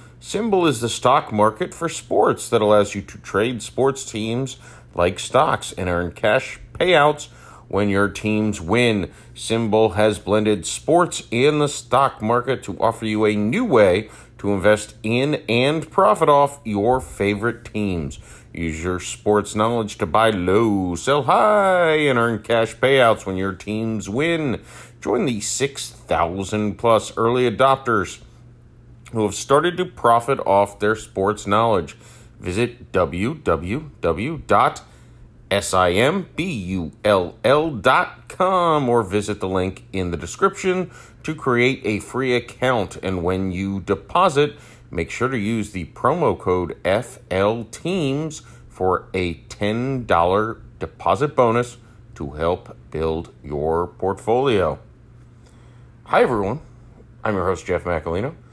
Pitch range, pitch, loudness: 100-125 Hz, 115 Hz, -20 LUFS